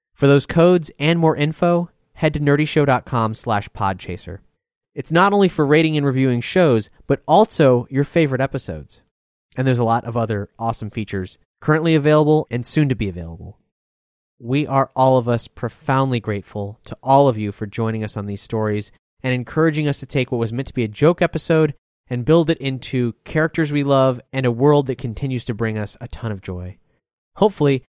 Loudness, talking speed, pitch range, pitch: -19 LUFS, 190 wpm, 110-150 Hz, 130 Hz